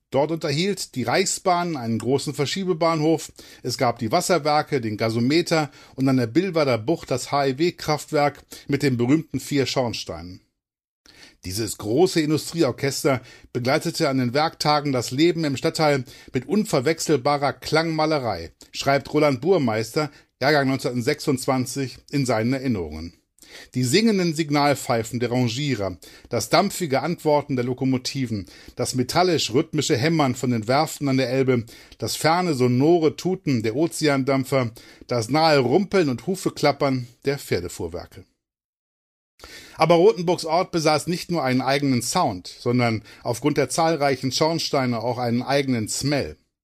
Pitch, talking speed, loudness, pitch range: 140 Hz, 125 wpm, -22 LUFS, 125-160 Hz